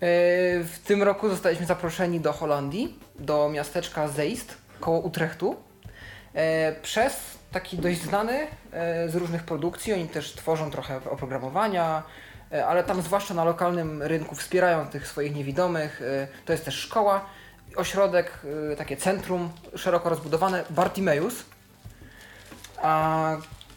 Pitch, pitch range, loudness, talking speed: 165 Hz, 150-180 Hz, -27 LUFS, 115 wpm